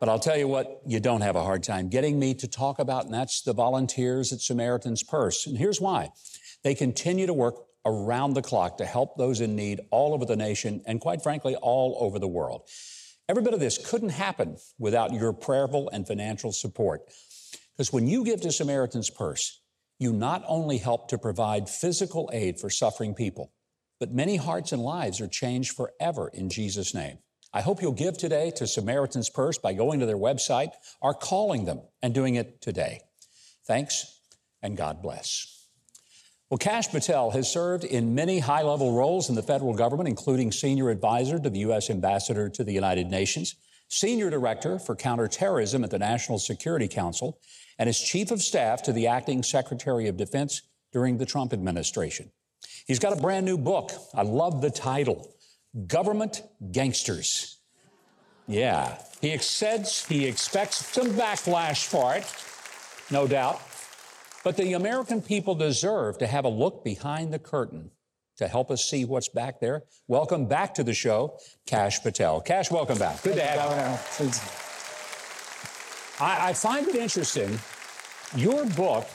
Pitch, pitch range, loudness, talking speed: 130 Hz, 115-155 Hz, -27 LUFS, 170 wpm